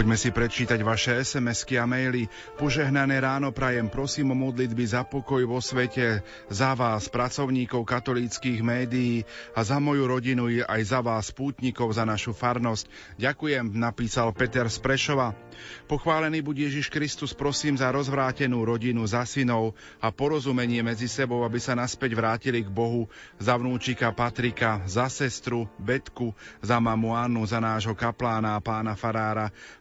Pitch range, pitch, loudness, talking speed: 115-130 Hz, 120 Hz, -27 LUFS, 145 wpm